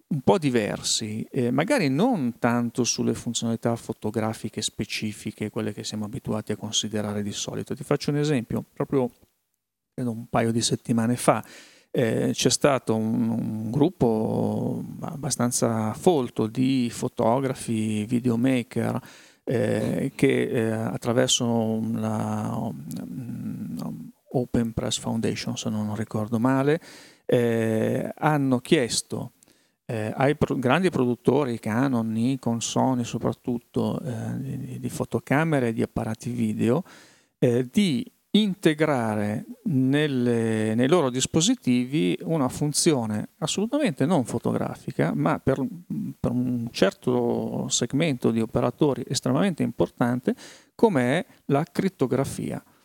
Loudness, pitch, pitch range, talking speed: -25 LUFS, 120 Hz, 110-135 Hz, 110 wpm